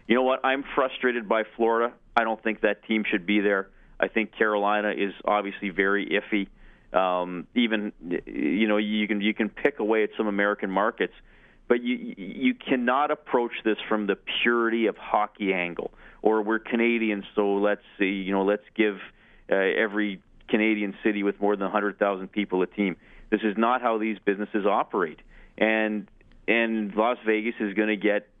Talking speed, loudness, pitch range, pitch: 180 wpm, -26 LUFS, 100-115 Hz, 105 Hz